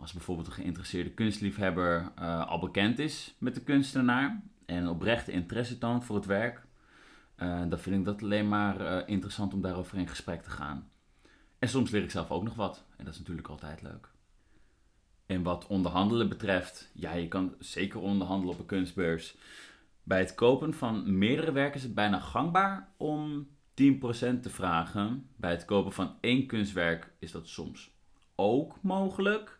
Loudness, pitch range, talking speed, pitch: -32 LUFS, 90-120 Hz, 170 wpm, 100 Hz